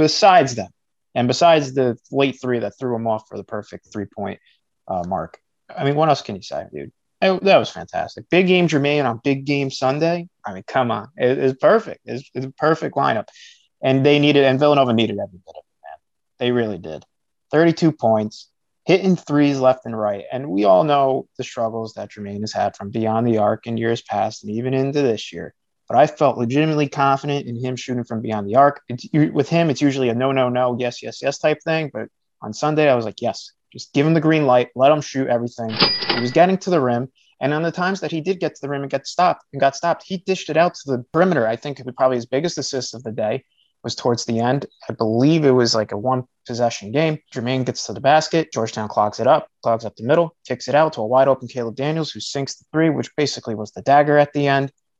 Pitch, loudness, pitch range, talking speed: 135 Hz, -19 LUFS, 115-150 Hz, 240 wpm